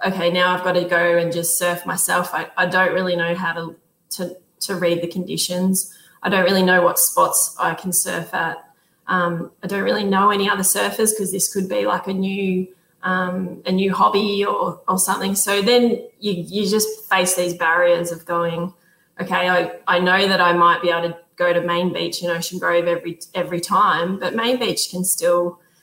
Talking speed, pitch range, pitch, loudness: 205 wpm, 170-190 Hz, 180 Hz, -19 LUFS